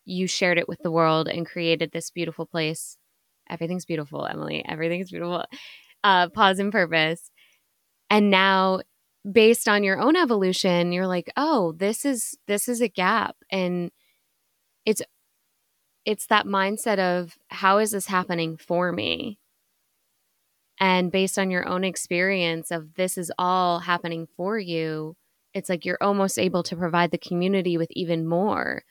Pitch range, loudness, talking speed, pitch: 170-195 Hz, -23 LUFS, 150 wpm, 180 Hz